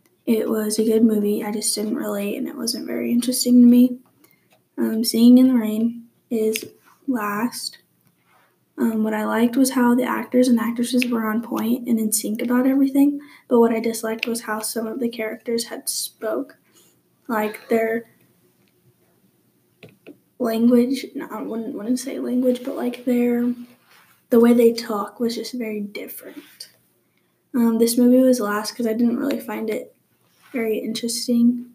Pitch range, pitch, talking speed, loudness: 225-250 Hz, 235 Hz, 165 wpm, -20 LUFS